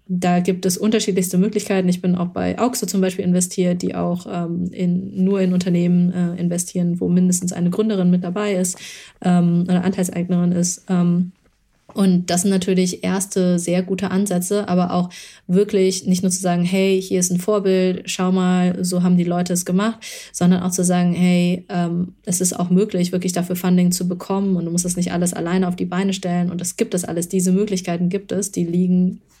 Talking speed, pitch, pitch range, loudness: 205 wpm, 180 Hz, 180-190 Hz, -19 LUFS